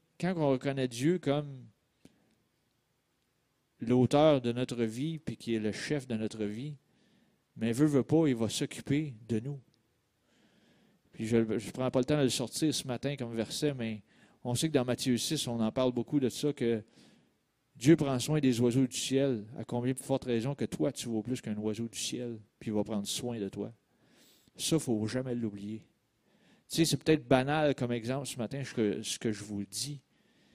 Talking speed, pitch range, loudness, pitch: 200 wpm, 115-140 Hz, -32 LUFS, 125 Hz